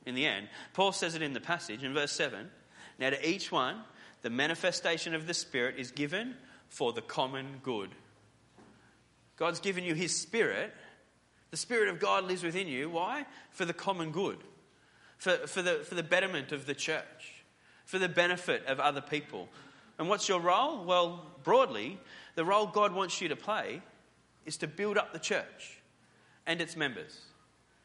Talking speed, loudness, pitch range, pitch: 175 wpm, -33 LUFS, 150-190 Hz, 170 Hz